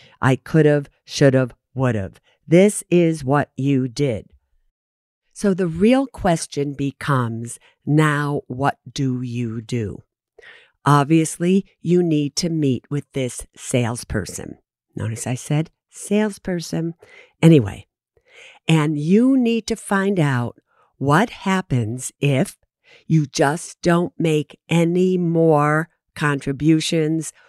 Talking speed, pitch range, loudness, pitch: 110 wpm, 130-170 Hz, -20 LUFS, 150 Hz